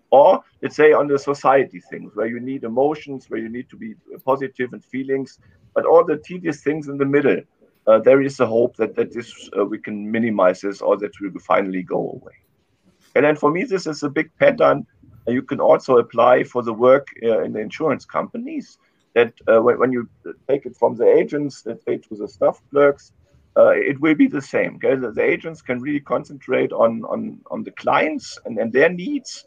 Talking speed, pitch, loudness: 215 wpm, 145 Hz, -19 LUFS